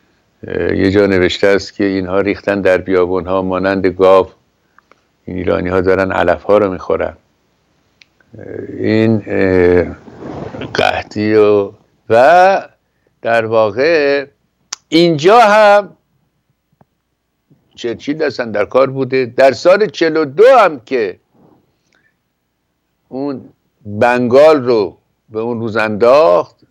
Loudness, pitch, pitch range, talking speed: -12 LUFS, 105 Hz, 95-135 Hz, 100 wpm